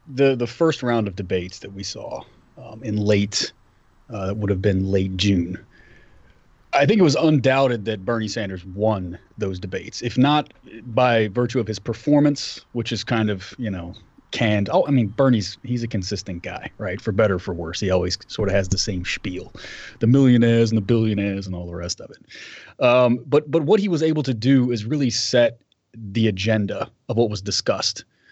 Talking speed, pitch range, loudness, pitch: 200 wpm, 100-125 Hz, -21 LUFS, 110 Hz